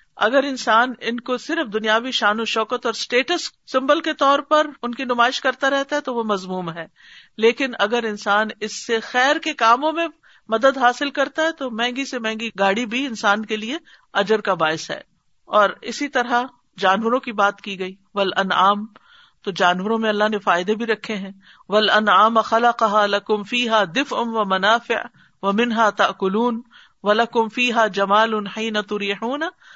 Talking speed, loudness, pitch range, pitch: 175 wpm, -20 LUFS, 210-255 Hz, 225 Hz